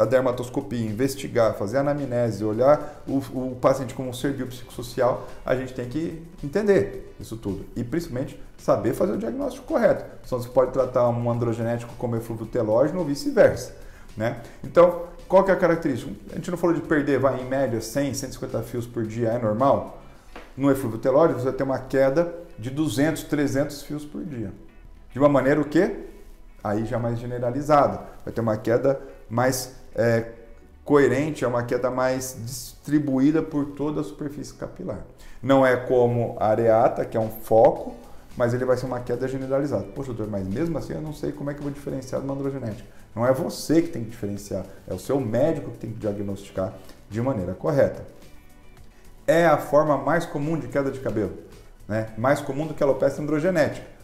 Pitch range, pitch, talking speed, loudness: 115-145 Hz, 130 Hz, 185 wpm, -24 LUFS